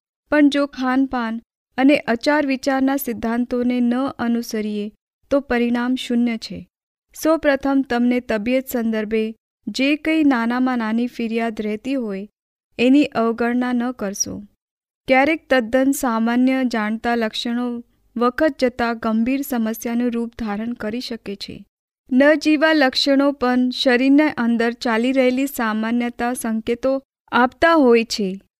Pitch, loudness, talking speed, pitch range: 245 Hz, -19 LUFS, 115 wpm, 230-265 Hz